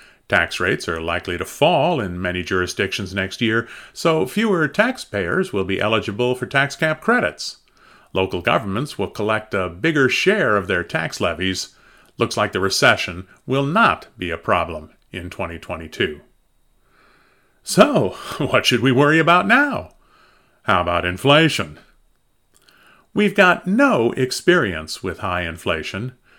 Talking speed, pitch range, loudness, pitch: 135 wpm, 90-150 Hz, -19 LUFS, 110 Hz